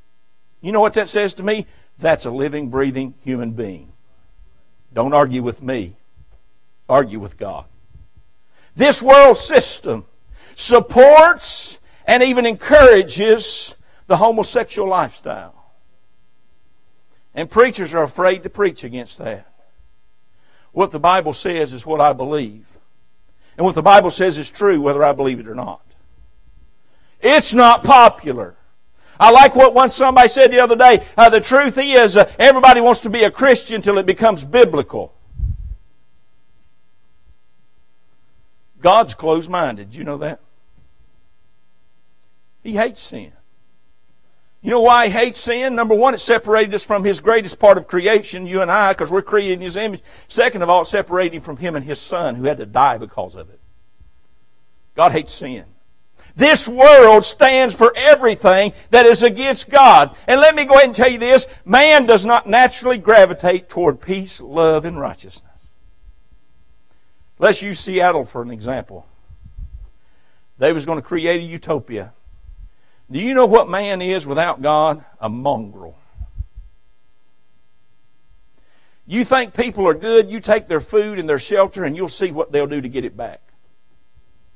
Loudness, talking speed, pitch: -13 LUFS, 150 wpm, 175 Hz